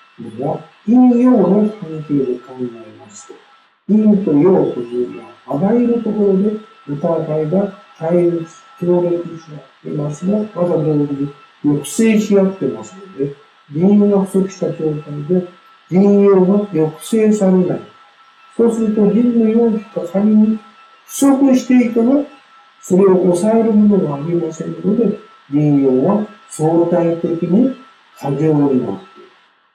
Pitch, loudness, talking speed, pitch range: 190 Hz, -15 LUFS, 260 characters per minute, 160-220 Hz